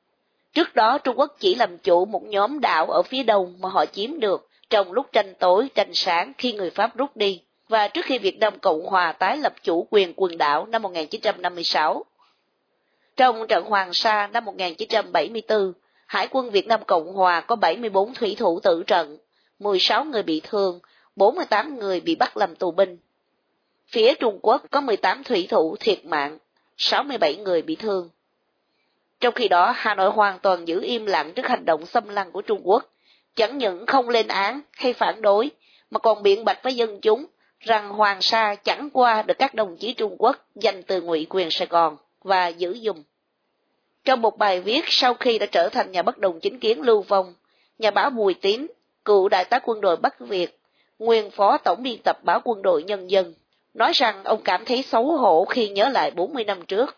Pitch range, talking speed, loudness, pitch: 185-245 Hz, 200 wpm, -22 LUFS, 210 Hz